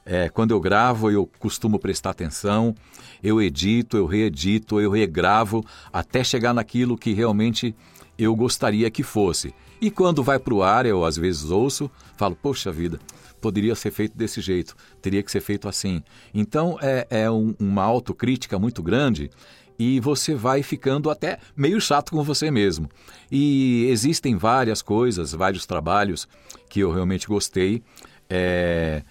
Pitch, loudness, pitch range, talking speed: 110 Hz, -22 LUFS, 95-125 Hz, 155 wpm